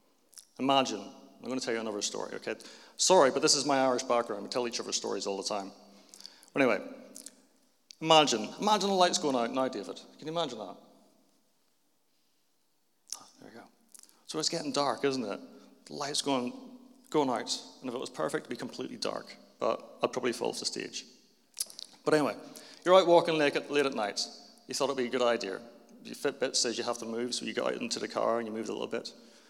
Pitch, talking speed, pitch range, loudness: 145 Hz, 220 wpm, 125-205 Hz, -30 LUFS